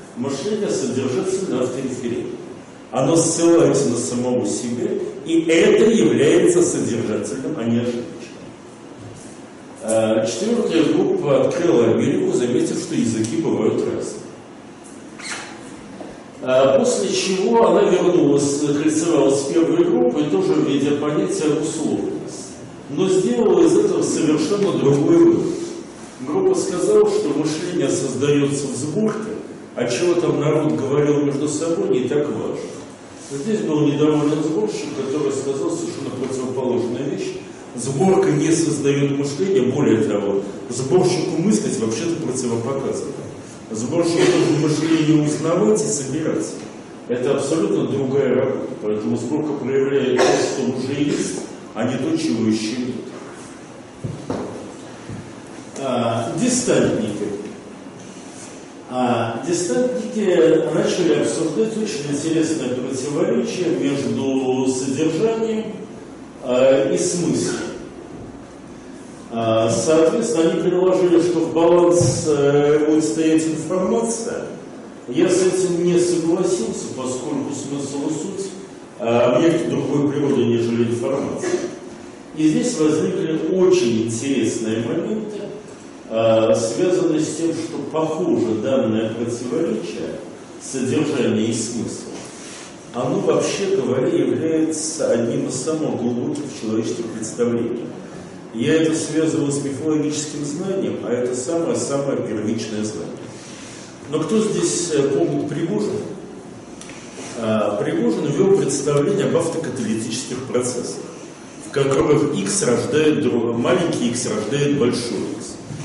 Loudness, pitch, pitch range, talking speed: -19 LUFS, 150 Hz, 125-175 Hz, 105 wpm